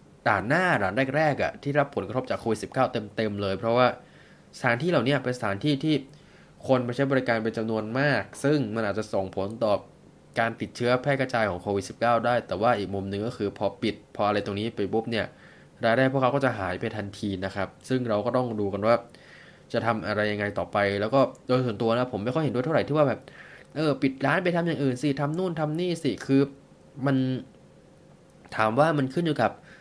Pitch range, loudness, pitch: 105-140 Hz, -26 LUFS, 120 Hz